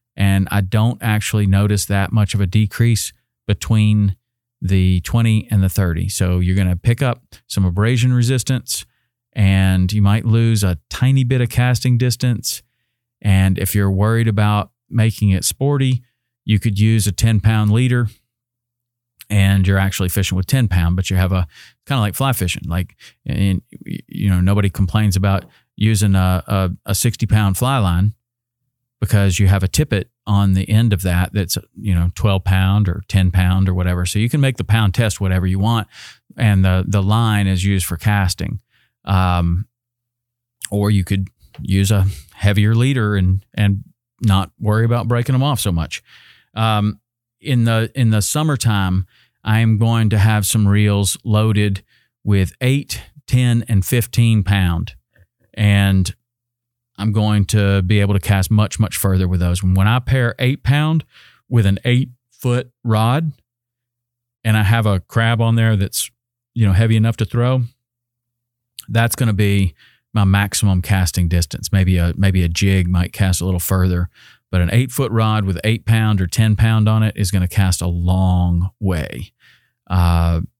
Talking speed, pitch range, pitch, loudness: 175 wpm, 95-120 Hz, 105 Hz, -17 LUFS